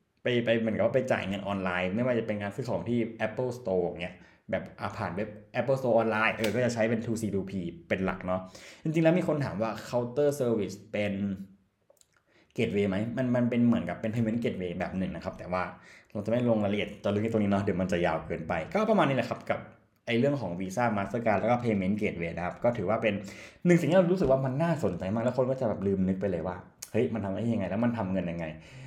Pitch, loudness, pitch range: 110 Hz, -29 LUFS, 95-120 Hz